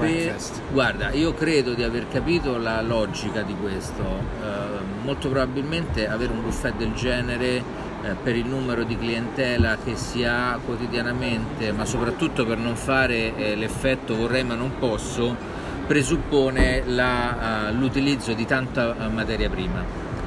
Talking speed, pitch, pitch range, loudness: 140 wpm, 120 Hz, 115-130 Hz, -24 LUFS